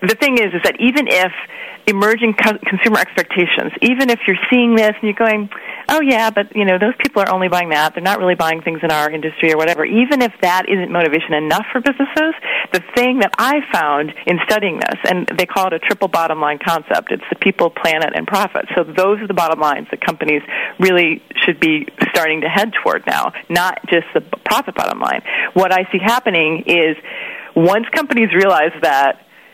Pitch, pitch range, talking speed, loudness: 200 Hz, 170-235 Hz, 205 wpm, -15 LUFS